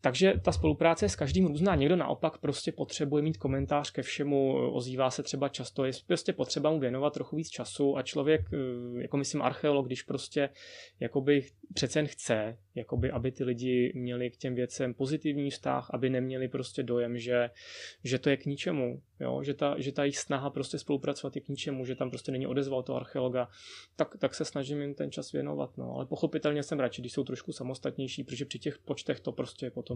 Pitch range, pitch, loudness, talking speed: 125-145 Hz, 135 Hz, -32 LUFS, 200 wpm